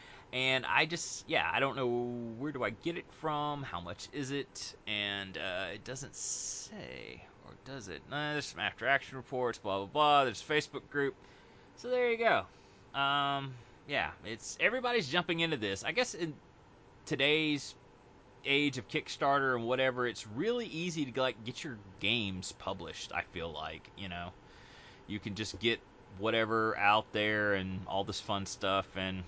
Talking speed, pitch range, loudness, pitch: 175 wpm, 100-145 Hz, -34 LUFS, 125 Hz